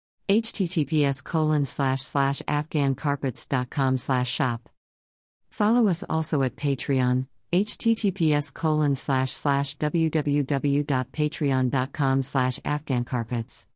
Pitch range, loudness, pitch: 130-155 Hz, -25 LUFS, 140 Hz